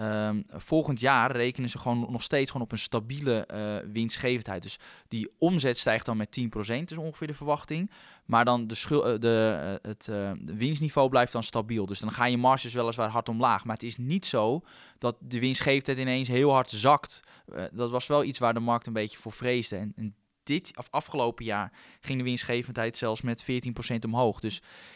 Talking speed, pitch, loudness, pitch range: 195 wpm, 120 Hz, -28 LUFS, 110-130 Hz